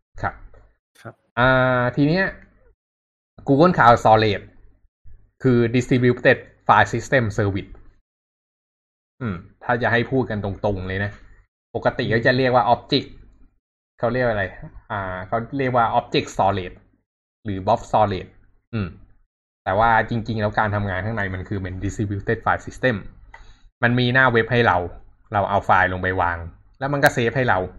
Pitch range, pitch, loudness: 95-120 Hz, 105 Hz, -20 LUFS